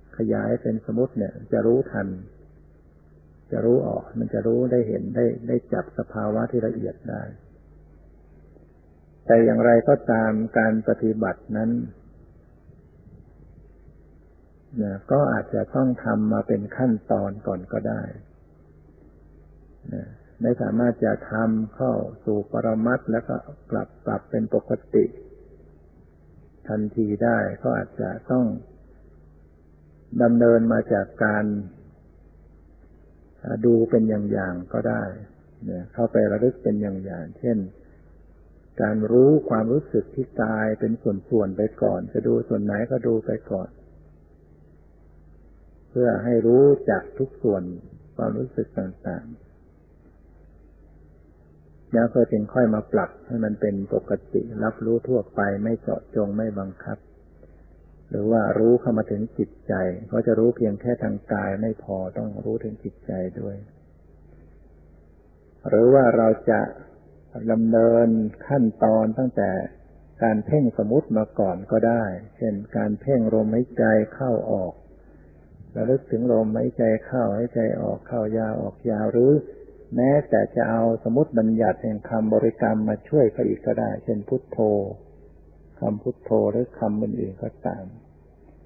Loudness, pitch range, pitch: -23 LUFS, 80-115 Hz, 105 Hz